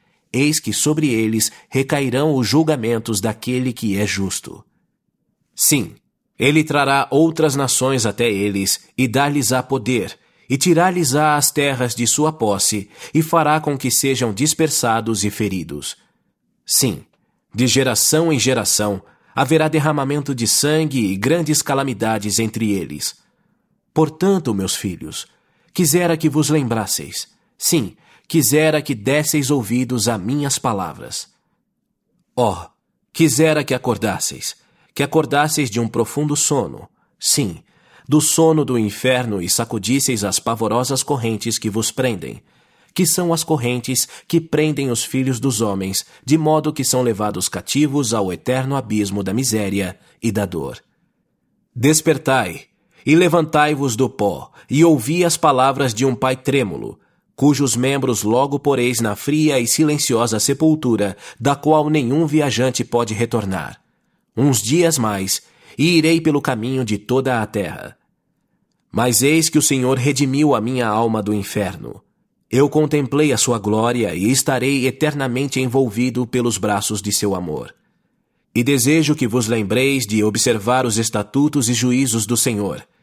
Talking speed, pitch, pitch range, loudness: 140 wpm, 130 Hz, 115-150 Hz, -17 LUFS